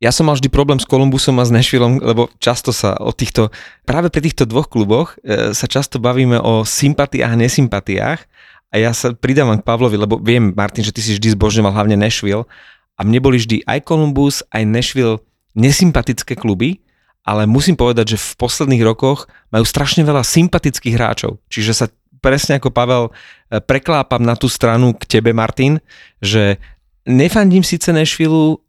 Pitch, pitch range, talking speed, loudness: 125 Hz, 110-140 Hz, 170 wpm, -14 LUFS